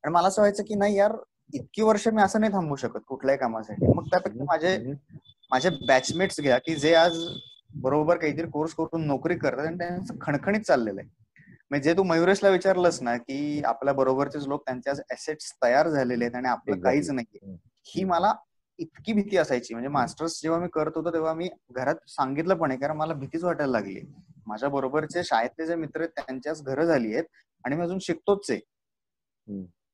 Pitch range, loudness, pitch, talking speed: 135-175 Hz, -26 LUFS, 155 Hz, 180 wpm